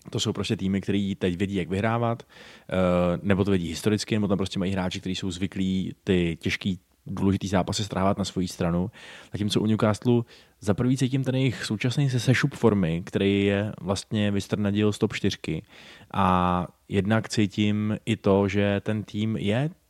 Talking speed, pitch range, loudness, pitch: 175 wpm, 95-110 Hz, -26 LUFS, 100 Hz